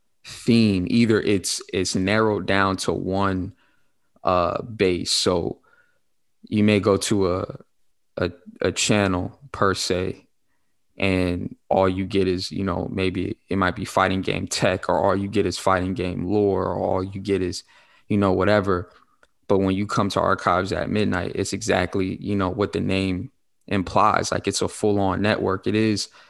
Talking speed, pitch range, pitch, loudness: 170 wpm, 95-105 Hz, 95 Hz, -22 LUFS